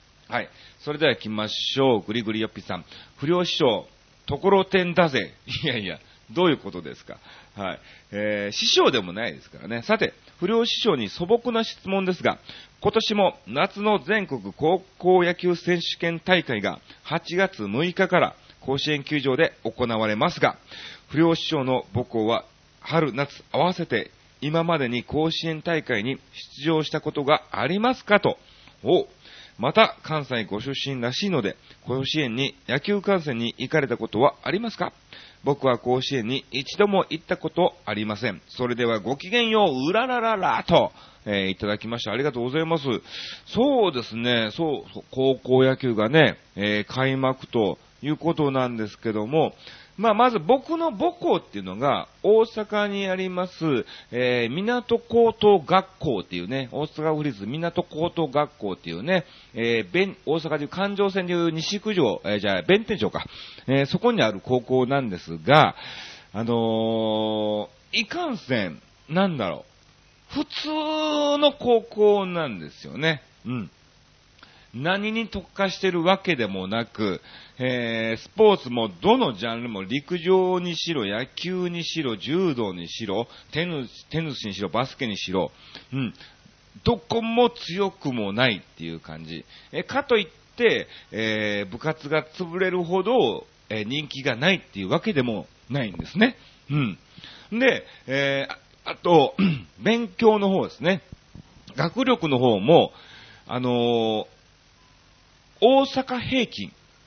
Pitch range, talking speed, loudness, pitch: 120-190 Hz, 275 characters per minute, -24 LUFS, 155 Hz